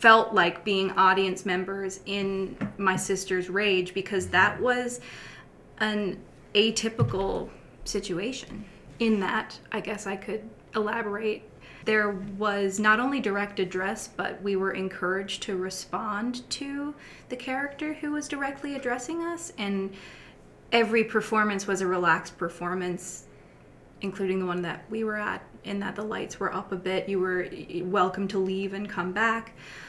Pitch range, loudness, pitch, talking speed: 190-220 Hz, -28 LUFS, 200 Hz, 145 wpm